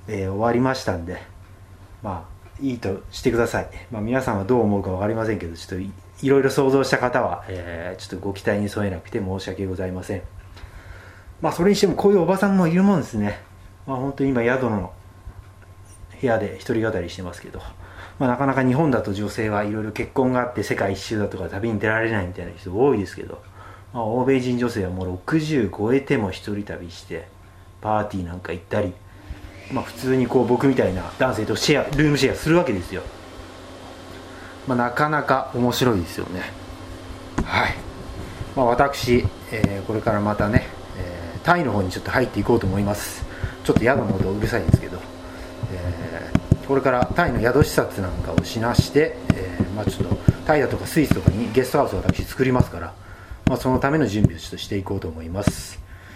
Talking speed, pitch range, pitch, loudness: 390 characters per minute, 95-125 Hz, 100 Hz, -22 LUFS